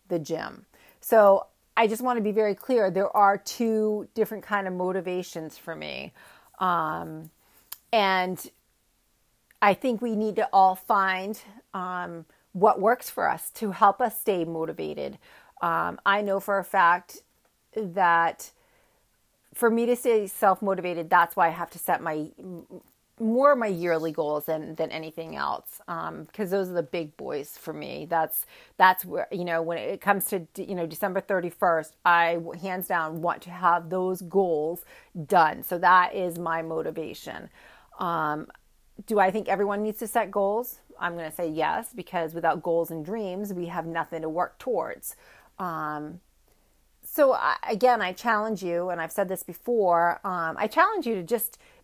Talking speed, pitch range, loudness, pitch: 170 wpm, 170-215 Hz, -26 LUFS, 185 Hz